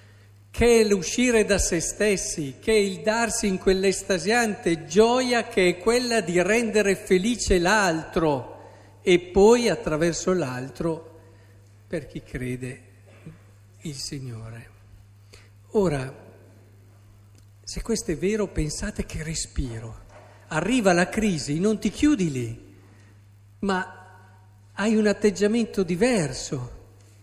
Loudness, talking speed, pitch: -23 LUFS, 110 wpm, 165 Hz